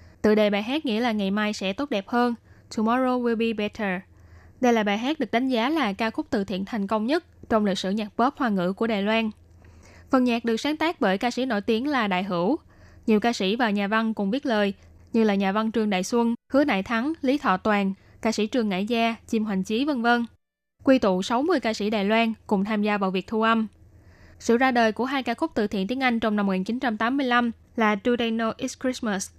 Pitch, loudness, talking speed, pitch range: 225 Hz, -24 LUFS, 245 wpm, 205-245 Hz